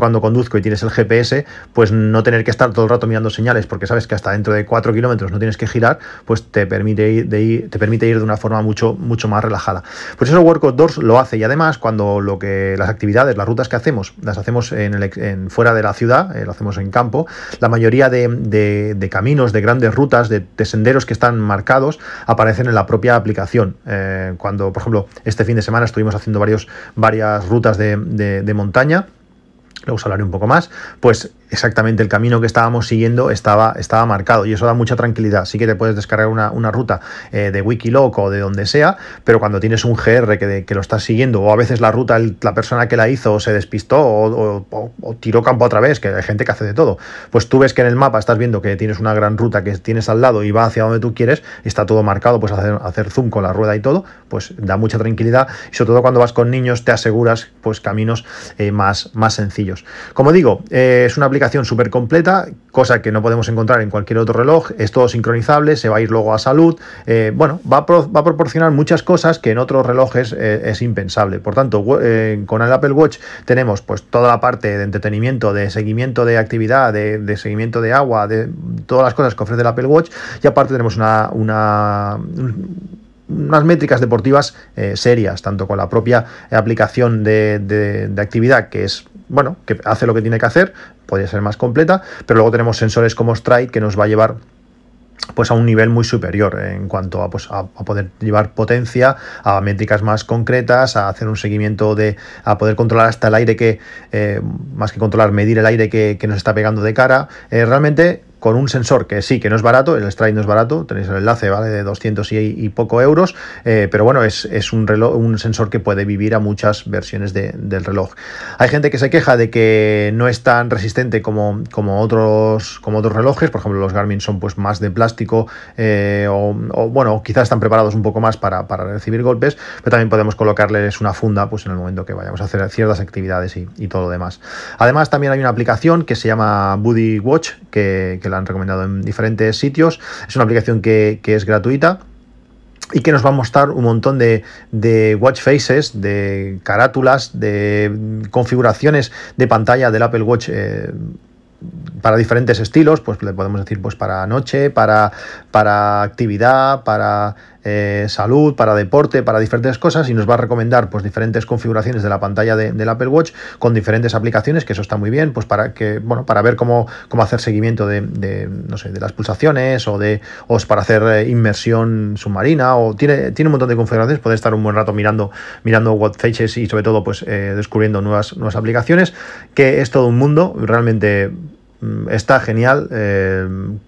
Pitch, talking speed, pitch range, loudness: 110 Hz, 215 wpm, 105-120 Hz, -14 LUFS